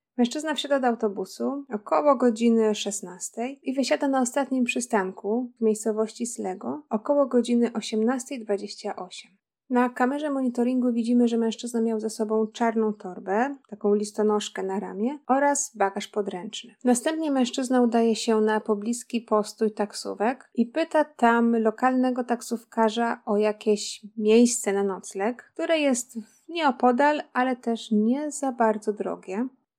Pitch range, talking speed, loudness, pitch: 215-255 Hz, 125 wpm, -25 LUFS, 230 Hz